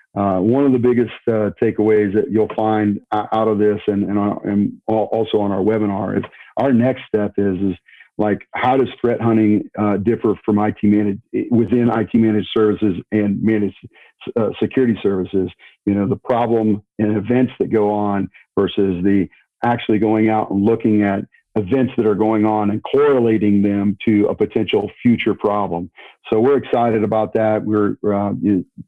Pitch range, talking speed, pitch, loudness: 100-110 Hz, 175 wpm, 105 Hz, -18 LUFS